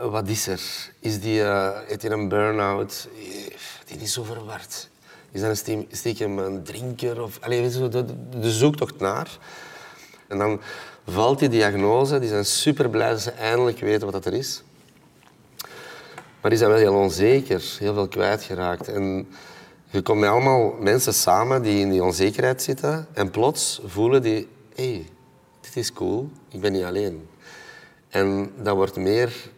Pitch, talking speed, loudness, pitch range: 110 Hz, 165 wpm, -23 LUFS, 100-120 Hz